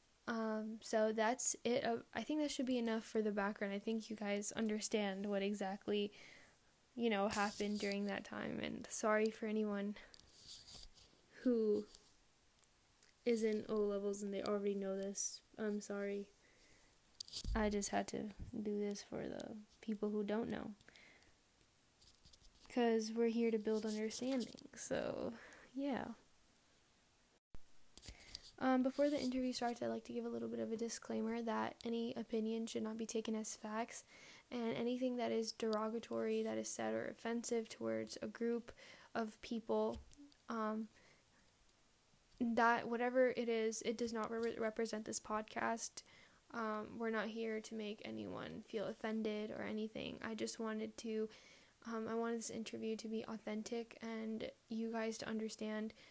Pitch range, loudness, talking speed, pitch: 210-230 Hz, -41 LUFS, 150 wpm, 220 Hz